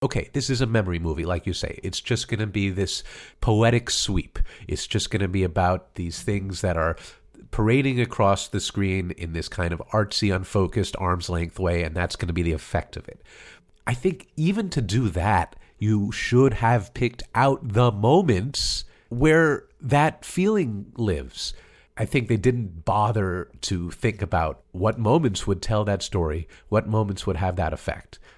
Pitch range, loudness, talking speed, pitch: 90-120 Hz, -24 LUFS, 175 wpm, 105 Hz